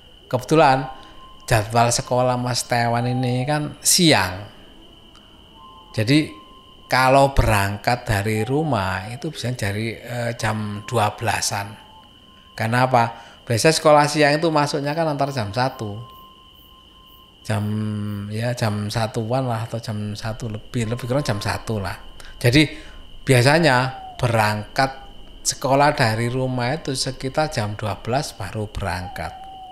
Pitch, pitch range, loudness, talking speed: 120 Hz, 105-135 Hz, -20 LUFS, 110 wpm